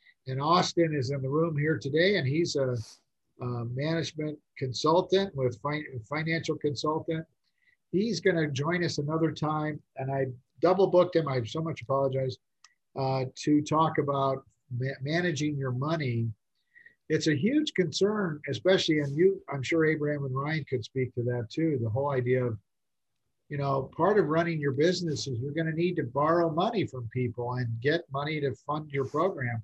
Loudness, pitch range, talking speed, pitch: -29 LUFS, 130-165 Hz, 175 wpm, 150 Hz